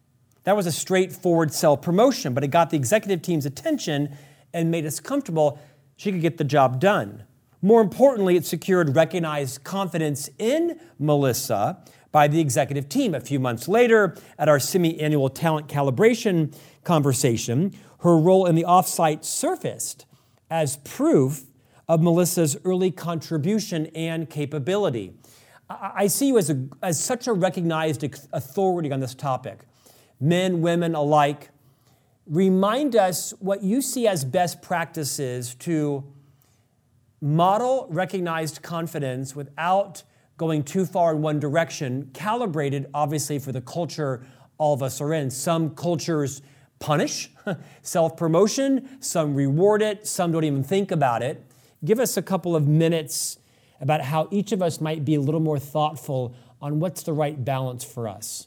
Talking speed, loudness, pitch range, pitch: 145 wpm, -23 LUFS, 140-180 Hz, 155 Hz